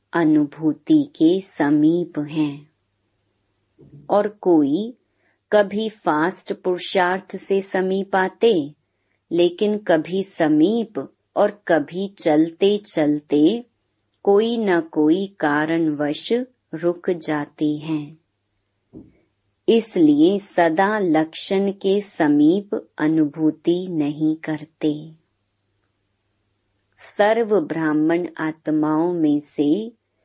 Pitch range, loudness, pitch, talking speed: 150-195 Hz, -20 LUFS, 165 Hz, 75 wpm